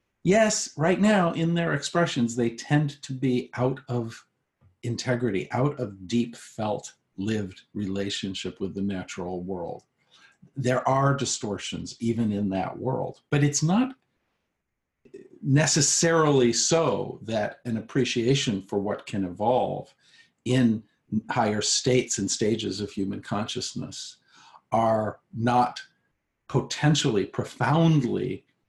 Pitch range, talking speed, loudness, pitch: 105-145 Hz, 115 wpm, -26 LUFS, 120 Hz